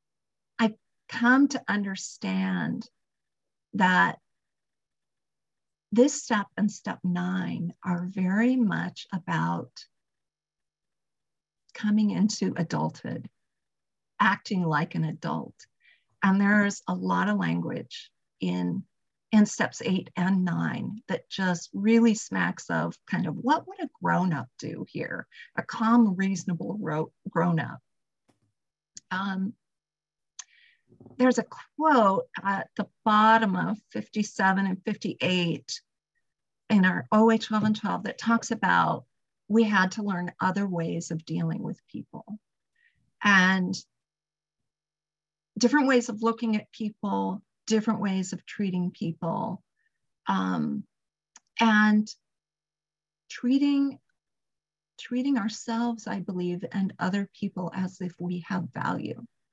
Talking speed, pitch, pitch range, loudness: 110 wpm, 195 Hz, 175-225 Hz, -27 LUFS